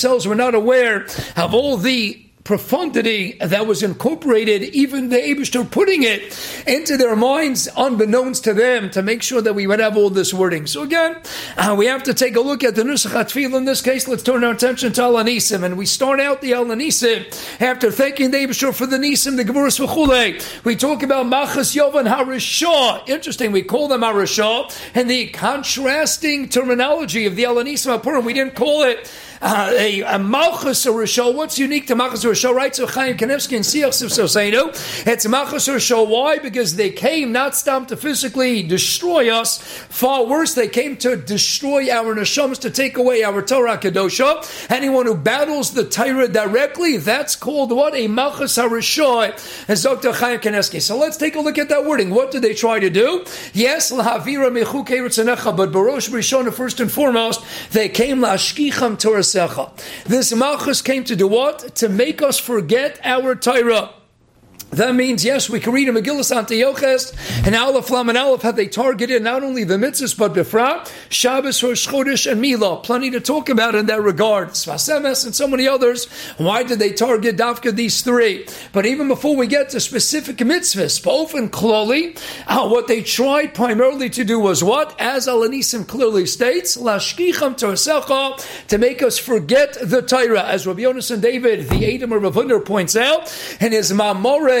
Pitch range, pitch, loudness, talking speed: 225-270 Hz, 245 Hz, -17 LUFS, 175 wpm